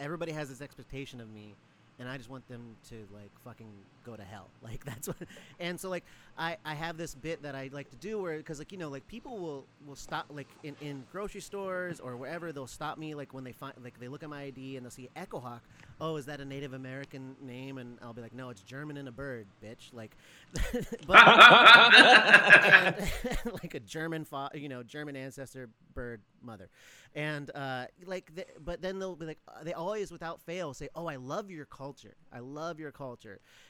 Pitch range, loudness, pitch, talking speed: 130-165 Hz, -20 LUFS, 140 Hz, 210 wpm